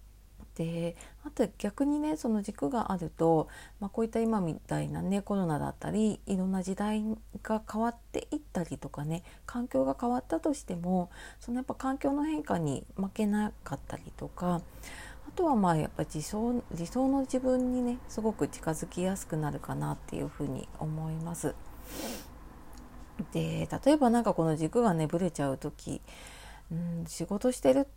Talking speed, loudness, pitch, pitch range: 320 characters per minute, -32 LUFS, 190 Hz, 160-235 Hz